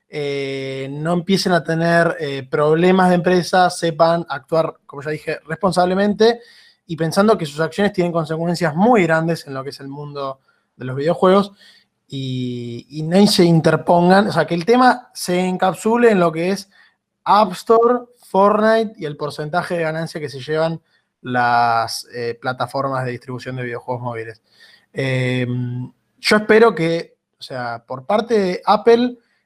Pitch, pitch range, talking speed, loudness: 165 Hz, 135-190 Hz, 160 wpm, -17 LUFS